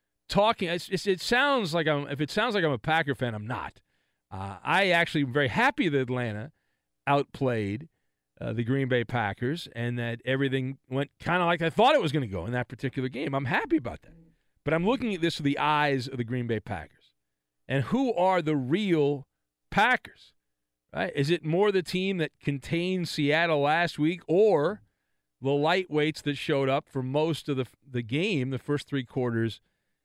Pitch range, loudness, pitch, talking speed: 125-170 Hz, -27 LUFS, 145 Hz, 195 wpm